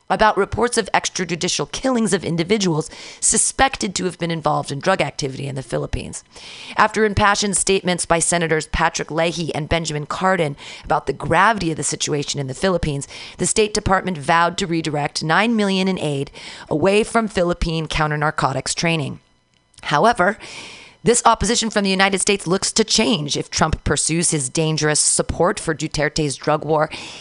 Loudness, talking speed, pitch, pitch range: -19 LUFS, 160 wpm, 170 Hz, 150-195 Hz